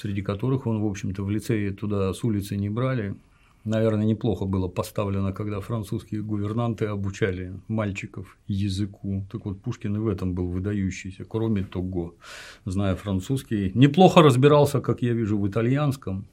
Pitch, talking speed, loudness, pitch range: 105 Hz, 150 wpm, -25 LUFS, 95-115 Hz